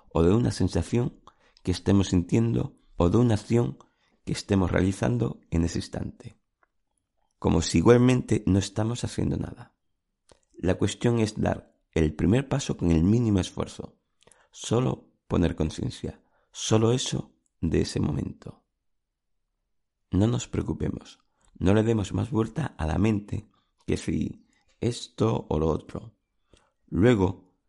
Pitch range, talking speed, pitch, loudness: 90-115 Hz, 130 wpm, 100 Hz, -26 LUFS